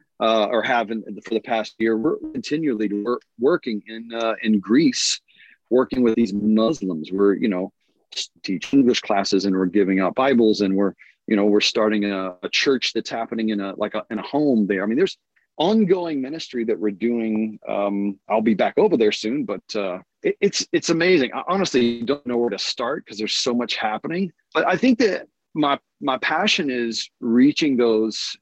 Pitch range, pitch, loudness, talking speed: 105-135 Hz, 115 Hz, -21 LUFS, 195 wpm